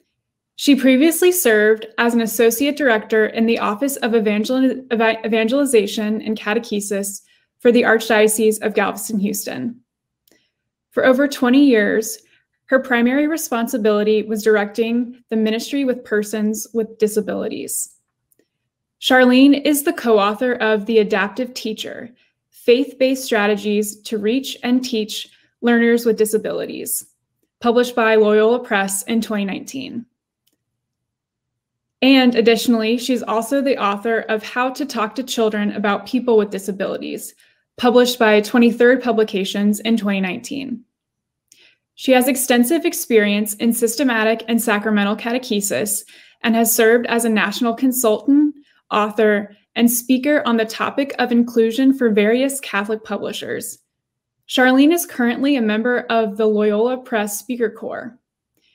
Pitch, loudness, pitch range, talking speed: 230 Hz, -17 LUFS, 215-255 Hz, 125 wpm